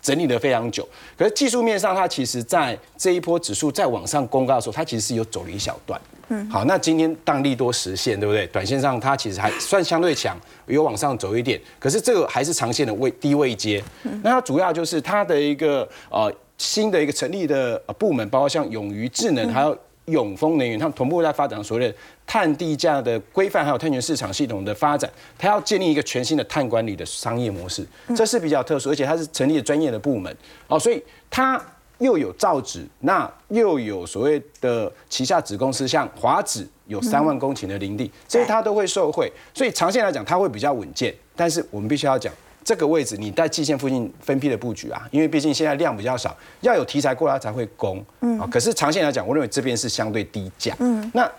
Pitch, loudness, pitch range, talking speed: 150 Hz, -22 LUFS, 120-180 Hz, 335 characters per minute